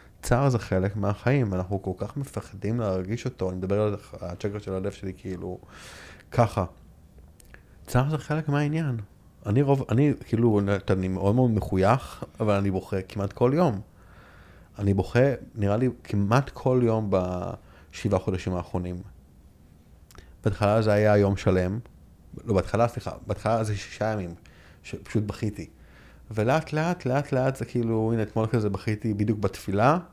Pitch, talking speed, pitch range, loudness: 105 Hz, 145 wpm, 95-120 Hz, -26 LUFS